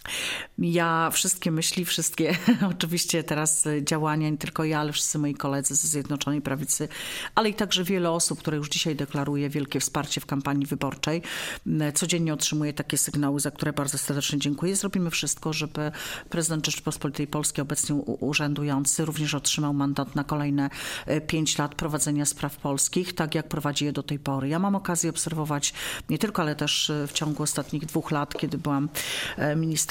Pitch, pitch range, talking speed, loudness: 150 Hz, 145-165 Hz, 165 wpm, -26 LUFS